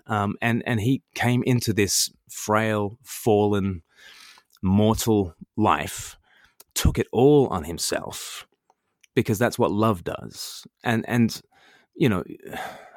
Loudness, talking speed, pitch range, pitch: -23 LUFS, 115 wpm, 100-120 Hz, 110 Hz